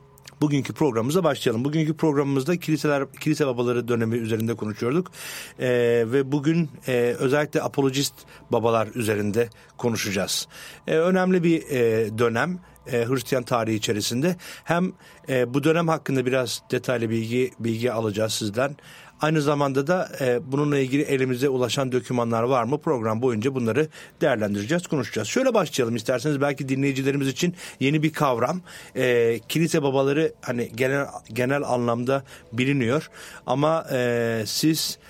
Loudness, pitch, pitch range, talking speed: -24 LUFS, 135 Hz, 120-150 Hz, 130 wpm